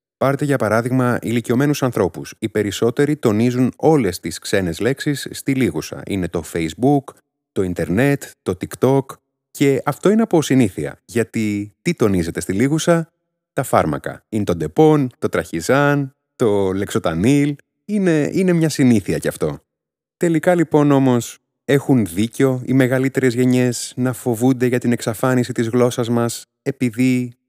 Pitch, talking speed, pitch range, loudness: 125 Hz, 140 wpm, 115-145 Hz, -18 LUFS